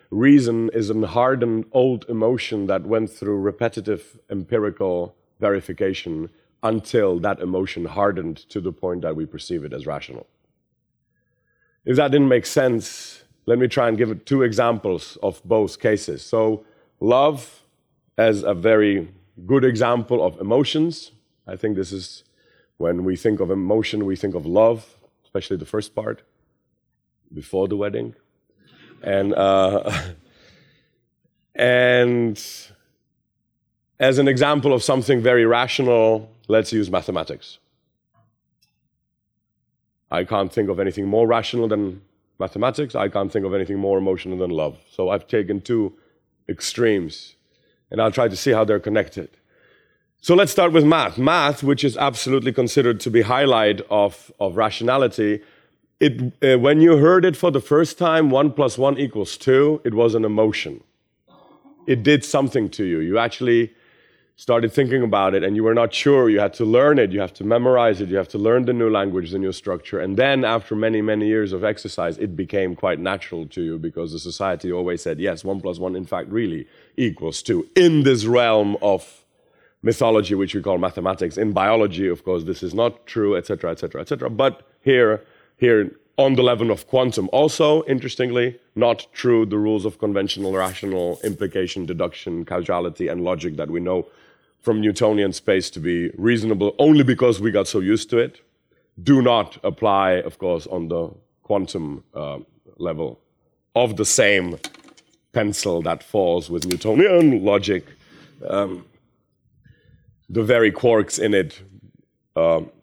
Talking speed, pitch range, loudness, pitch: 160 wpm, 95-125 Hz, -20 LUFS, 110 Hz